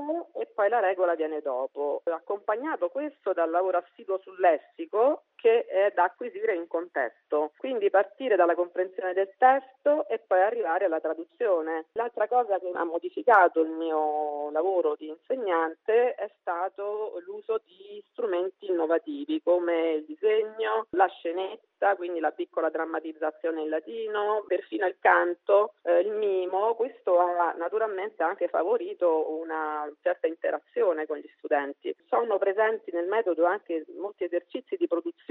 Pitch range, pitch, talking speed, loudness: 165-225 Hz, 185 Hz, 140 wpm, -27 LUFS